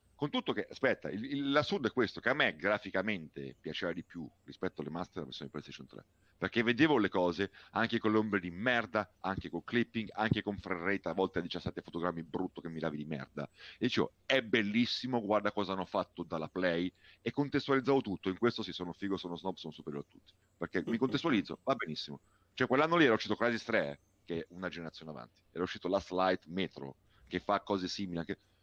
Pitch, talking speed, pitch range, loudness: 95 Hz, 210 wpm, 85-110 Hz, -34 LUFS